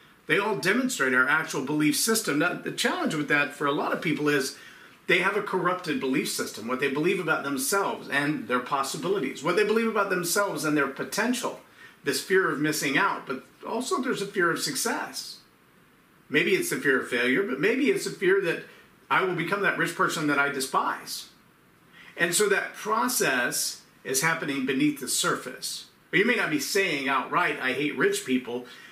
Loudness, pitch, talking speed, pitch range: -26 LUFS, 165 Hz, 195 wpm, 140-200 Hz